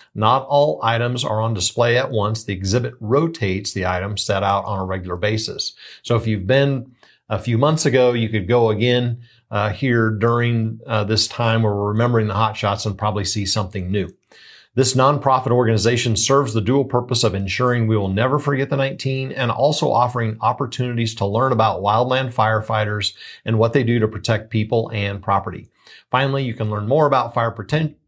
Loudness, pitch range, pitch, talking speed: -19 LUFS, 105-125 Hz, 115 Hz, 190 wpm